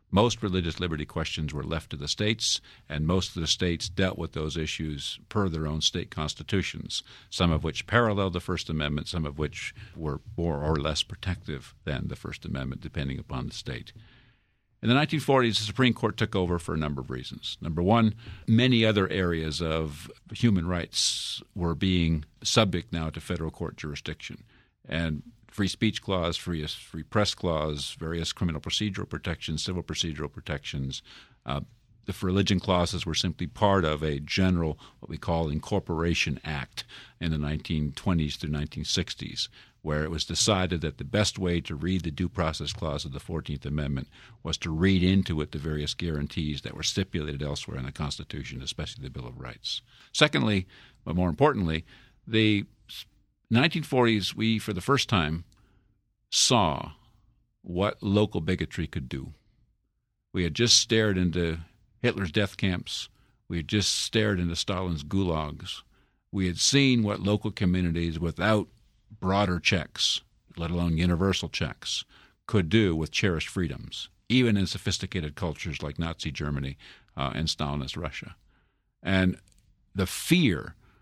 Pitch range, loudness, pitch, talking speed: 80-105 Hz, -28 LUFS, 90 Hz, 155 wpm